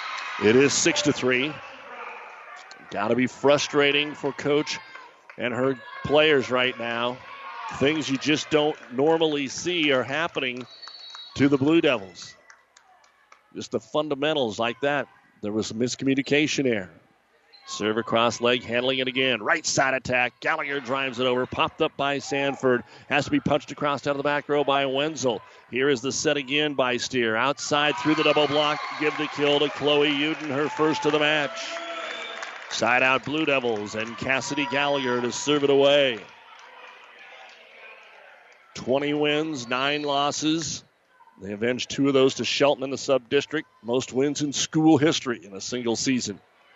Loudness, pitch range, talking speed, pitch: -24 LUFS, 125-150 Hz, 160 wpm, 140 Hz